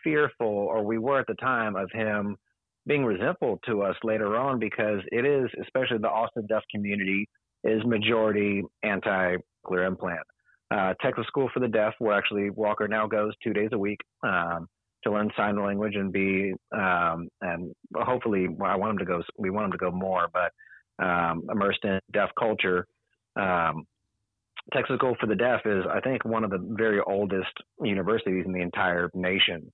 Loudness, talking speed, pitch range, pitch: -27 LUFS, 180 wpm, 95-110 Hz, 105 Hz